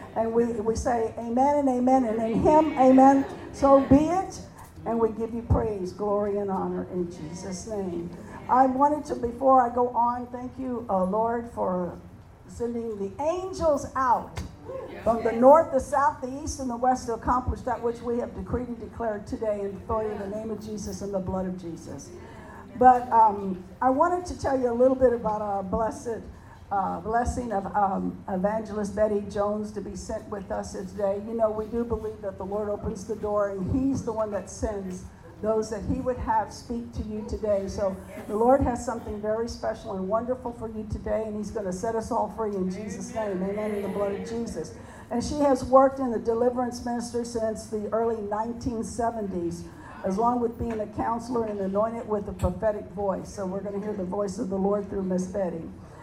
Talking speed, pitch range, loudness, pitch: 205 wpm, 205-240 Hz, -26 LUFS, 220 Hz